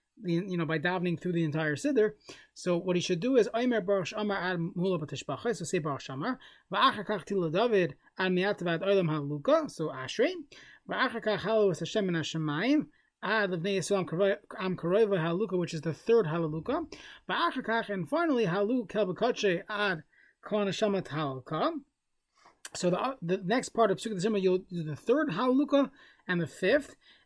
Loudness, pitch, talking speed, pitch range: -30 LUFS, 195 Hz, 160 wpm, 170-220 Hz